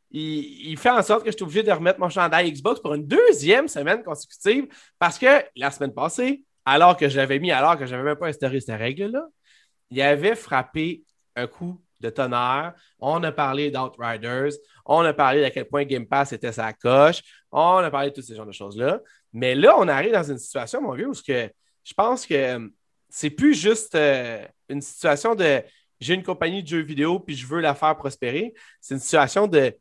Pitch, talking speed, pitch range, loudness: 150 Hz, 210 wpm, 135-185 Hz, -21 LUFS